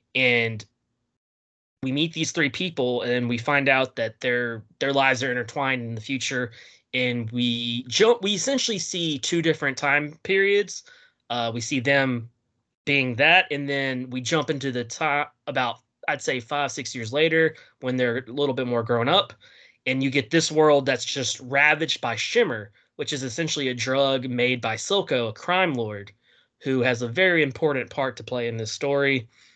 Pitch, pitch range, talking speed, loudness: 135 Hz, 120-150 Hz, 180 wpm, -23 LUFS